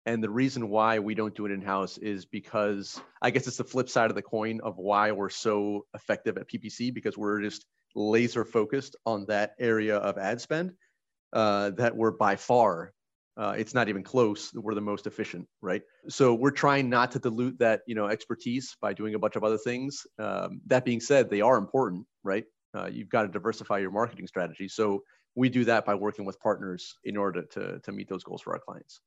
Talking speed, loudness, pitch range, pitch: 215 wpm, -29 LUFS, 105-120 Hz, 110 Hz